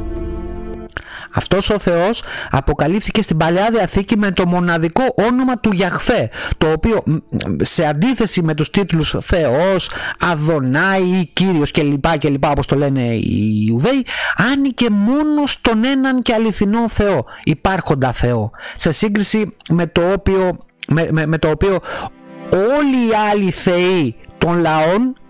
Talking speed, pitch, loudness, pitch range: 140 wpm, 180 Hz, -16 LUFS, 155-215 Hz